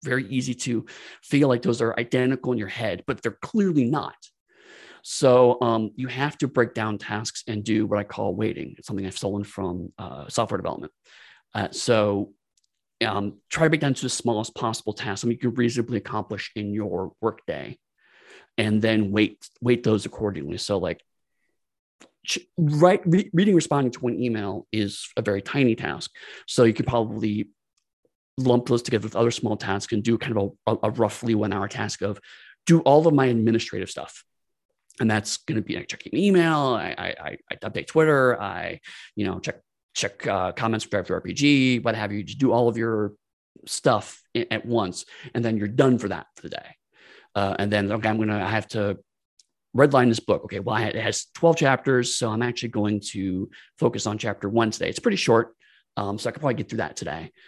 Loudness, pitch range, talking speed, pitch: -24 LUFS, 105-125 Hz, 195 wpm, 115 Hz